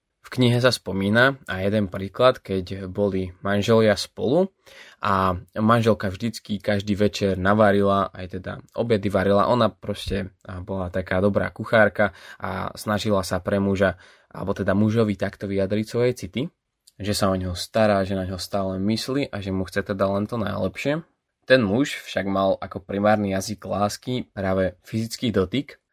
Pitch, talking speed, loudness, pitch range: 100 Hz, 155 wpm, -23 LUFS, 95-110 Hz